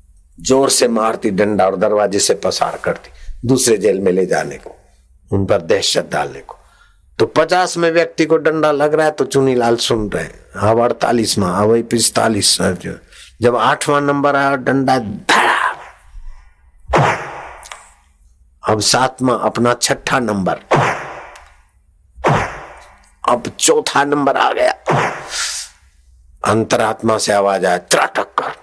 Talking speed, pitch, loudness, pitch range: 125 wpm, 110 Hz, -15 LUFS, 85-135 Hz